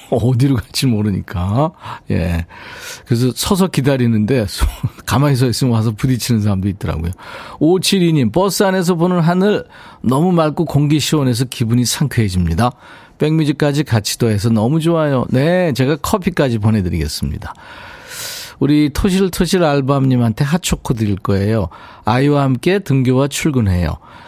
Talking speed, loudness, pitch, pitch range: 325 characters per minute, -16 LUFS, 135 Hz, 115-165 Hz